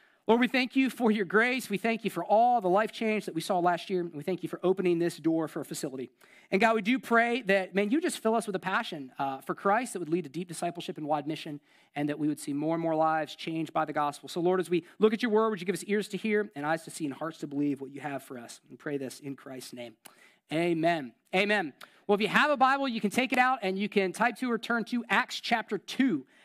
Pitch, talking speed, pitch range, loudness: 185 Hz, 290 wpm, 160-225 Hz, -29 LUFS